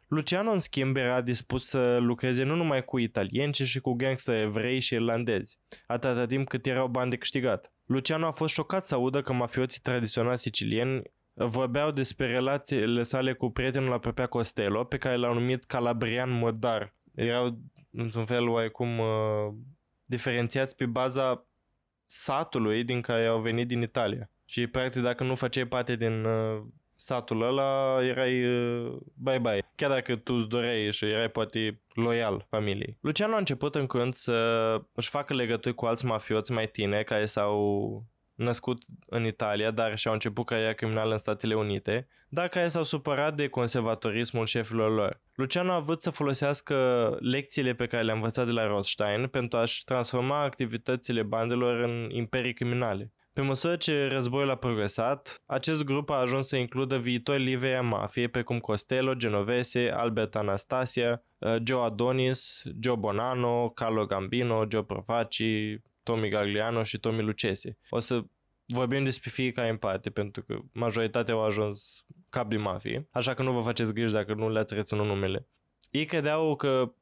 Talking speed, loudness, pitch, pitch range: 160 wpm, -29 LUFS, 120 Hz, 115-130 Hz